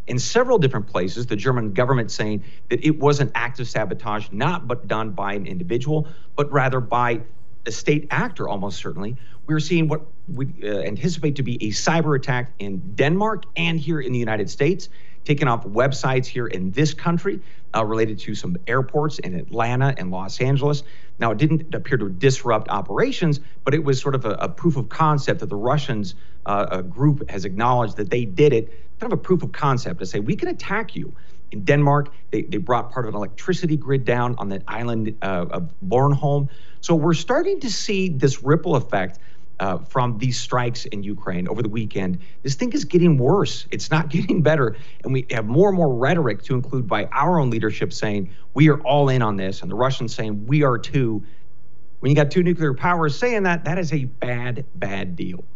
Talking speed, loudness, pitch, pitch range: 205 wpm, -22 LUFS, 135 Hz, 115-155 Hz